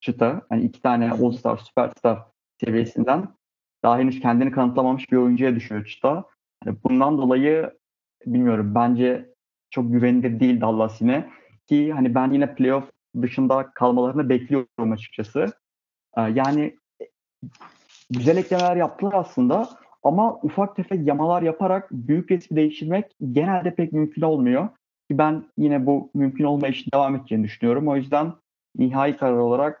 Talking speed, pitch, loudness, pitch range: 135 wpm, 135 Hz, -22 LUFS, 125-160 Hz